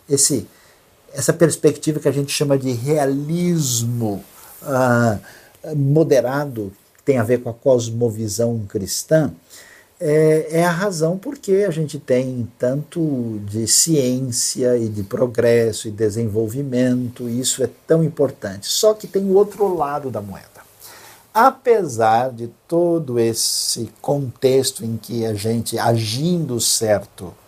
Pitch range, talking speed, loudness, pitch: 115-155 Hz, 130 wpm, -19 LUFS, 125 Hz